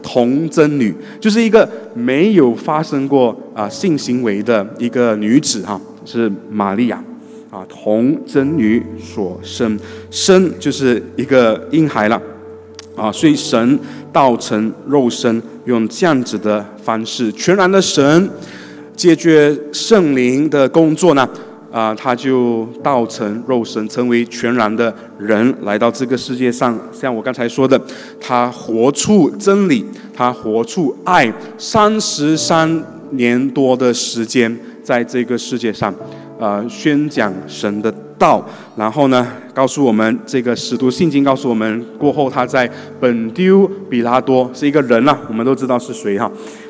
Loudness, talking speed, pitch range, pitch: -15 LUFS, 210 characters per minute, 115-150 Hz, 125 Hz